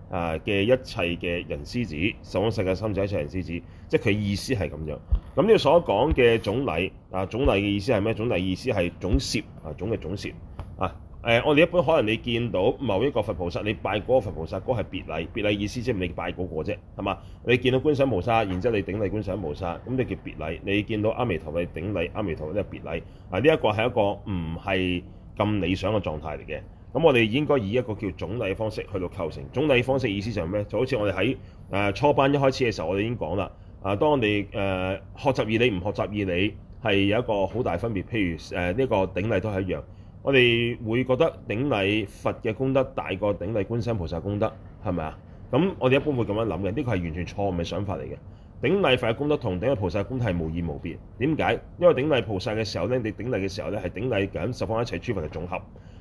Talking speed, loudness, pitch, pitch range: 350 characters per minute, -26 LUFS, 100 Hz, 90-115 Hz